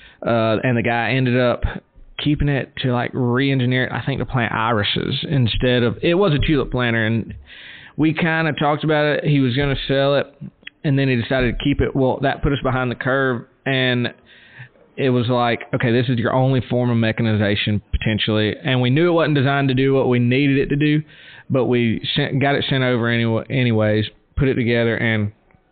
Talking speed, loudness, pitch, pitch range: 210 wpm, -19 LUFS, 125 Hz, 115-140 Hz